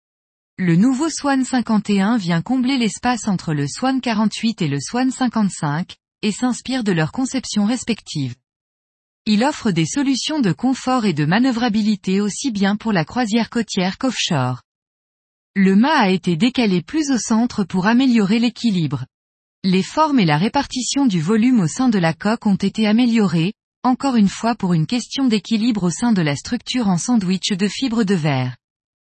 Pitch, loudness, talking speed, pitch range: 215 Hz, -18 LUFS, 165 wpm, 180-250 Hz